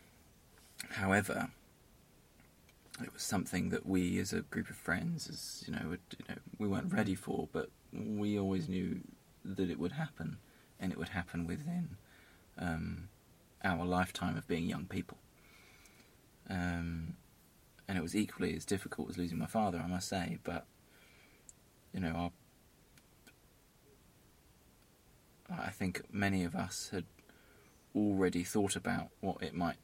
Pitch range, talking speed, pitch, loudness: 85-105 Hz, 140 wpm, 90 Hz, -38 LUFS